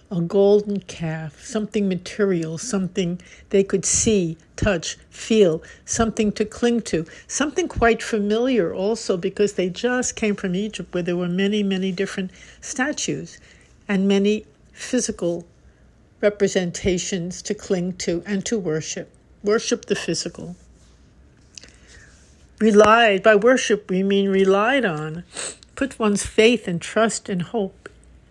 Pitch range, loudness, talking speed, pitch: 185-220 Hz, -21 LUFS, 125 wpm, 200 Hz